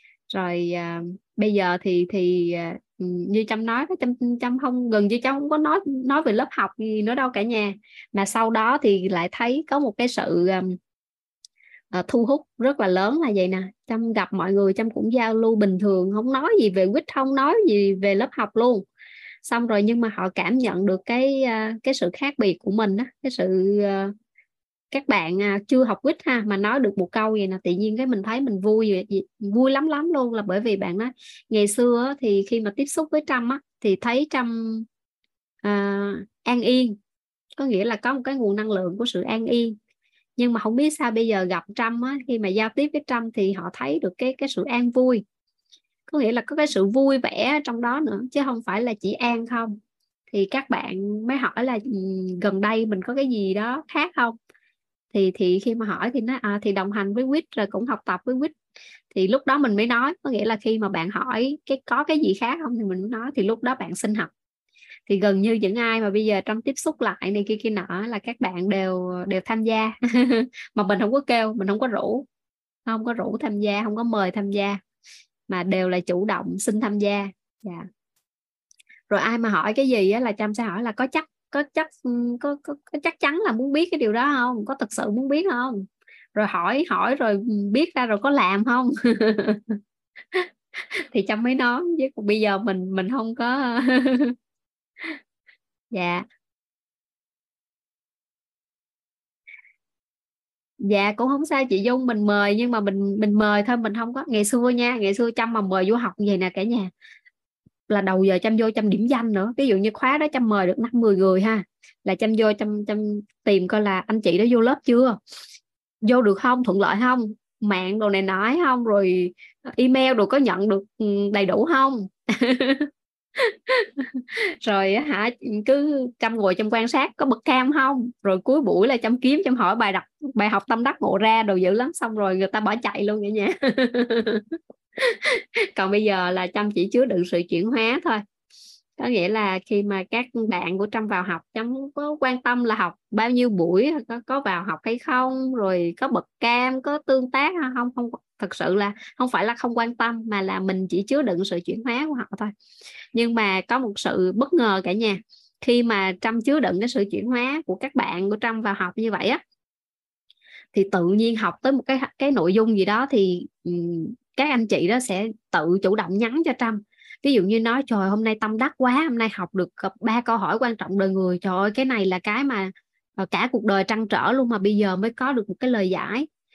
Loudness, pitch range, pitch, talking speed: -22 LUFS, 200-255 Hz, 225 Hz, 220 wpm